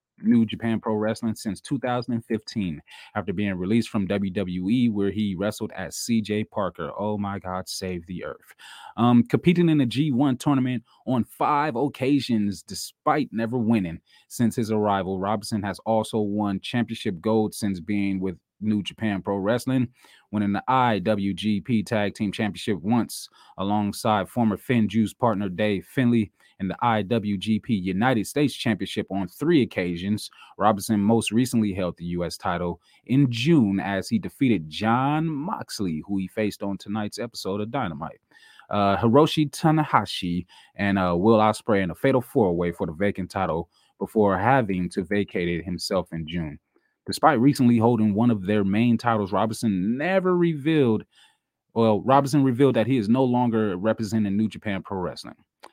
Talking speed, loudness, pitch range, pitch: 155 wpm, -24 LUFS, 100-120 Hz, 110 Hz